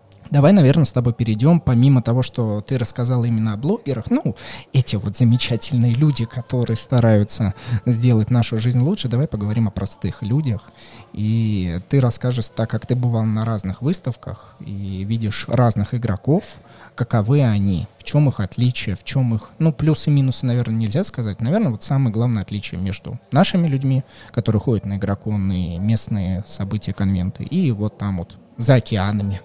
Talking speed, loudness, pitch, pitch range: 165 wpm, -19 LUFS, 115 Hz, 105-130 Hz